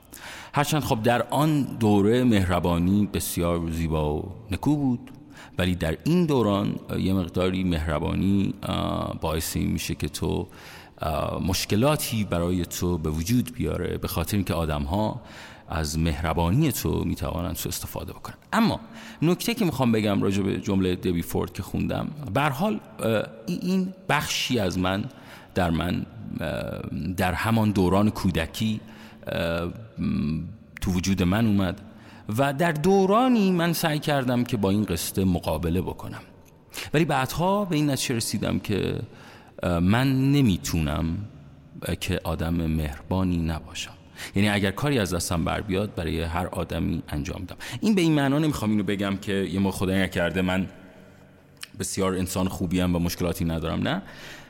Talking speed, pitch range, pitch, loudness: 135 wpm, 85-115 Hz, 95 Hz, -25 LUFS